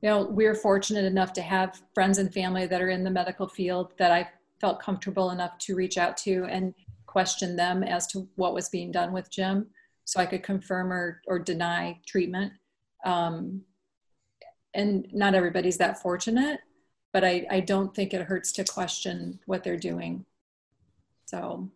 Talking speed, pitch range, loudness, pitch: 175 wpm, 180-195 Hz, -28 LUFS, 185 Hz